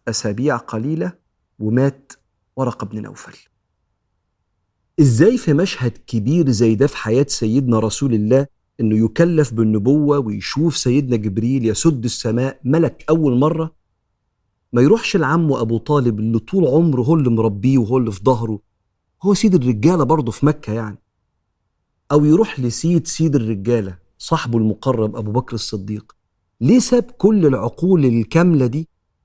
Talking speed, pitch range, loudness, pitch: 135 wpm, 110-155 Hz, -17 LUFS, 130 Hz